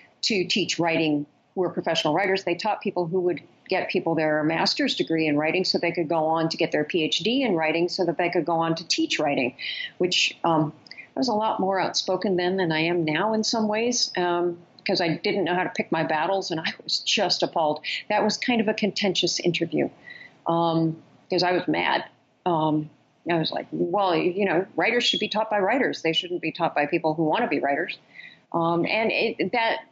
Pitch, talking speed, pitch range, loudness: 175 Hz, 220 wpm, 160-195 Hz, -24 LUFS